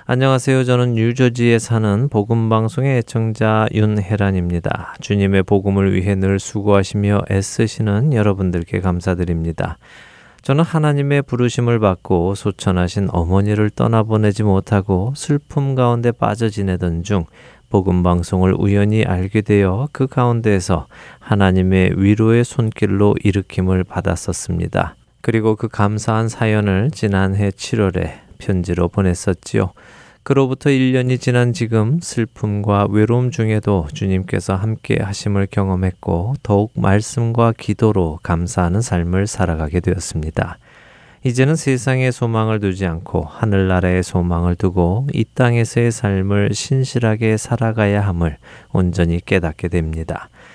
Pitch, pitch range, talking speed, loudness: 105 Hz, 95-115 Hz, 305 characters per minute, -17 LUFS